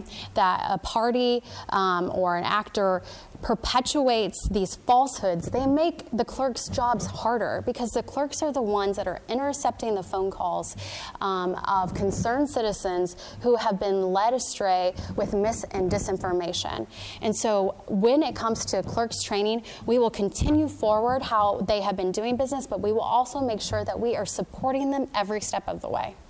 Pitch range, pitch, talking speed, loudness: 195-245 Hz, 215 Hz, 170 wpm, -26 LUFS